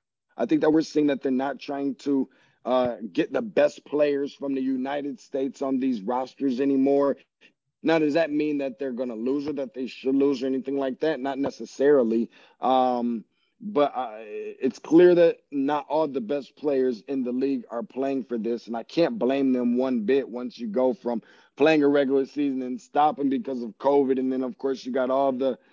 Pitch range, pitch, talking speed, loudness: 130-145 Hz, 135 Hz, 210 wpm, -25 LUFS